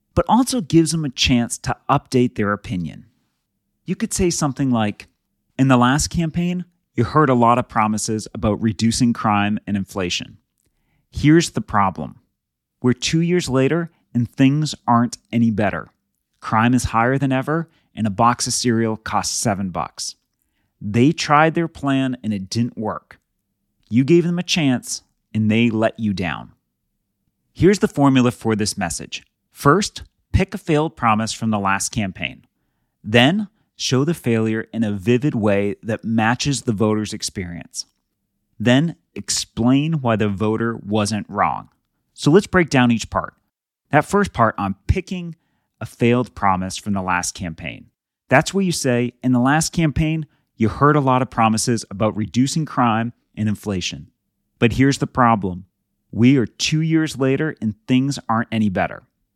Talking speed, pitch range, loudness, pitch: 160 wpm, 105-145 Hz, -19 LUFS, 120 Hz